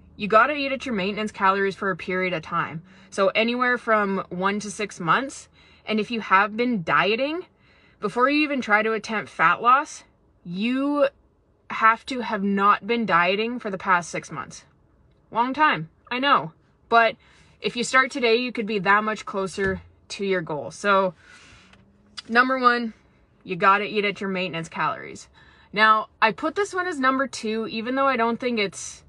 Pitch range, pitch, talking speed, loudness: 190-240 Hz, 215 Hz, 180 wpm, -22 LUFS